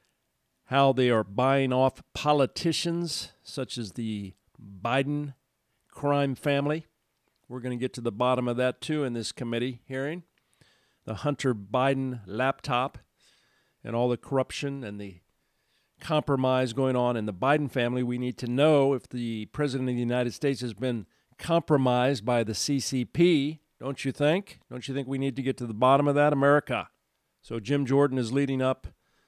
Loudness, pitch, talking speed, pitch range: -27 LUFS, 130 Hz, 170 wpm, 120-140 Hz